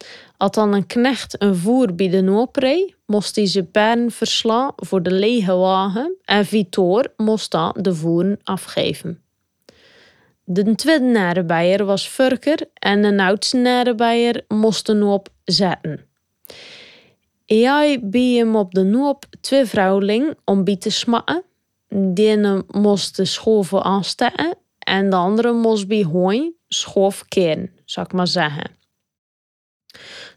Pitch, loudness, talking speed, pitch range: 205 Hz, -18 LUFS, 135 wpm, 190-240 Hz